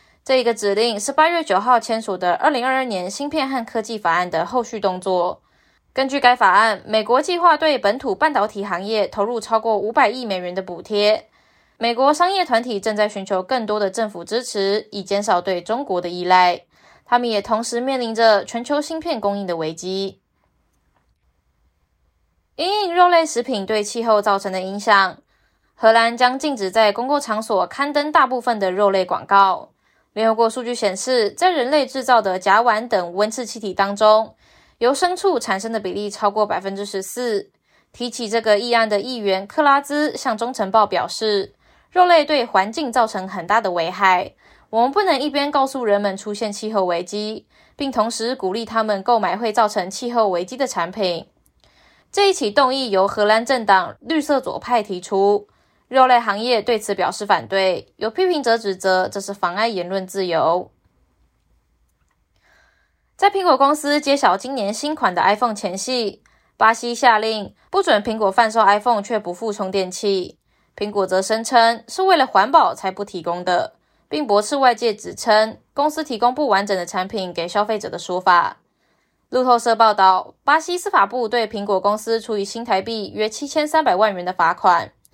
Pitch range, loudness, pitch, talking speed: 195-250 Hz, -19 LUFS, 220 Hz, 275 characters per minute